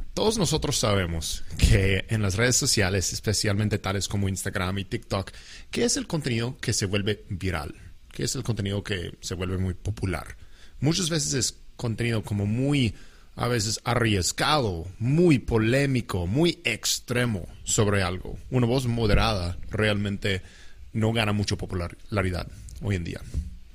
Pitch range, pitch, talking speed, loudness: 95-120 Hz, 105 Hz, 145 wpm, -26 LUFS